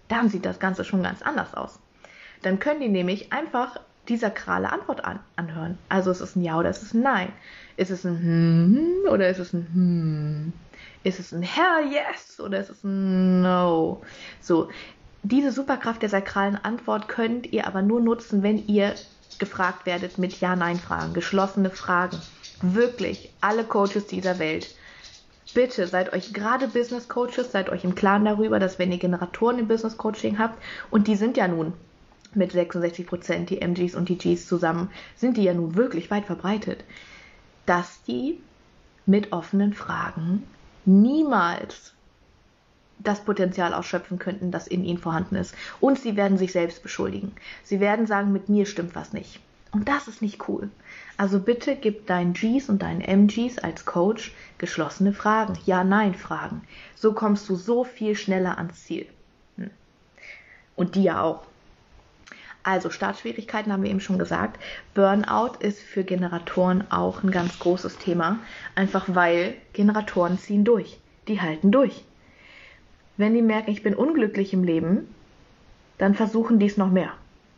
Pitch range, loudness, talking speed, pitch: 180-215 Hz, -24 LUFS, 165 wpm, 195 Hz